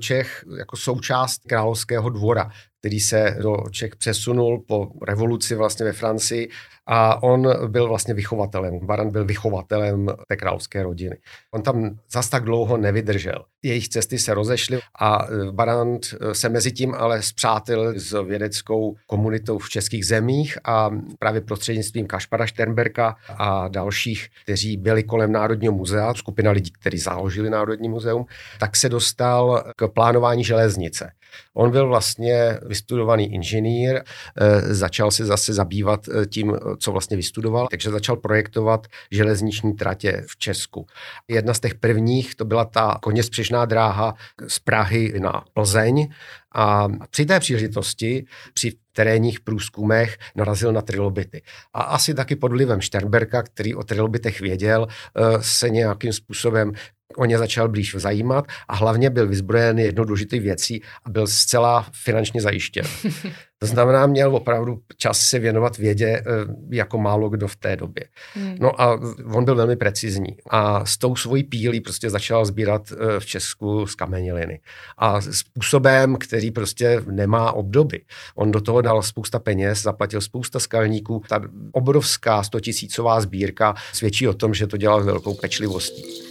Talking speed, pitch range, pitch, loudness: 140 wpm, 105-120 Hz, 110 Hz, -21 LUFS